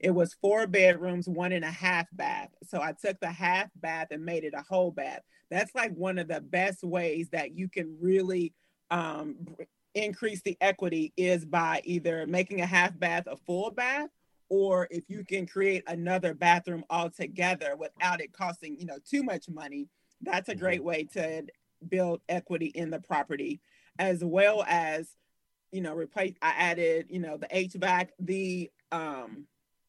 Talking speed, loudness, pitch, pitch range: 175 wpm, -30 LUFS, 180 Hz, 165-190 Hz